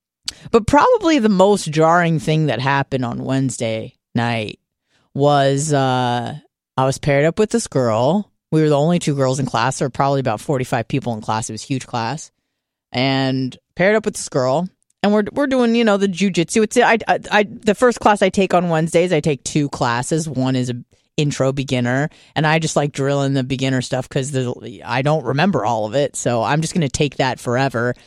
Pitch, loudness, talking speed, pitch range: 140 Hz, -18 LUFS, 210 wpm, 130-170 Hz